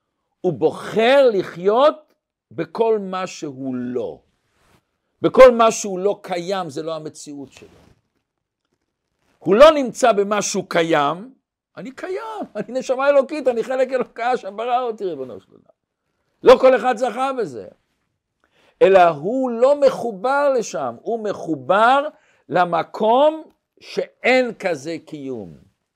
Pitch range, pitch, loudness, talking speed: 180-265 Hz, 230 Hz, -18 LUFS, 120 wpm